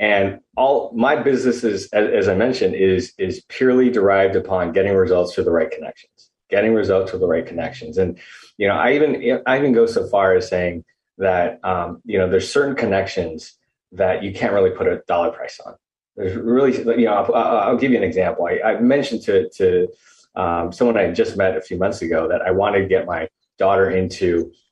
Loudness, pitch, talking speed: -18 LUFS, 100 Hz, 205 wpm